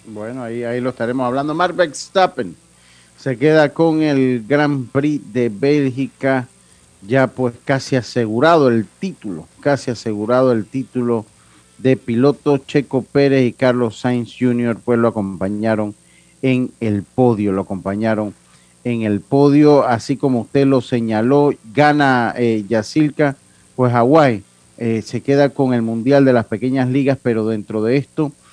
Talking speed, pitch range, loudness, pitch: 145 wpm, 110-140 Hz, -17 LUFS, 125 Hz